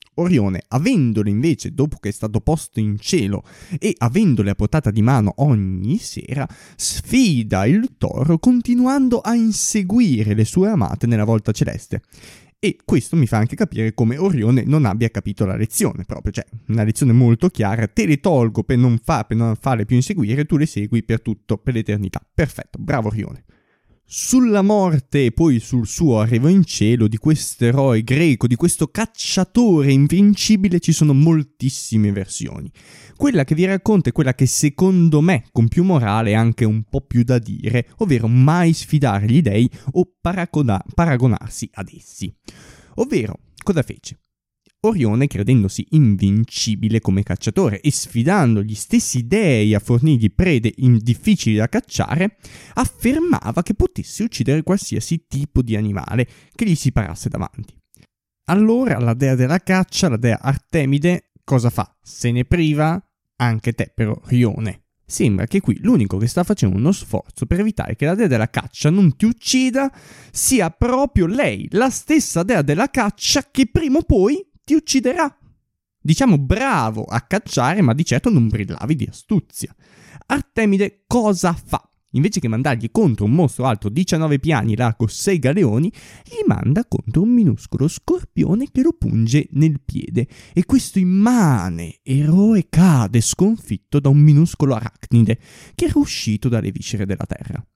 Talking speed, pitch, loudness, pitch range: 155 wpm, 130 Hz, -18 LUFS, 110-175 Hz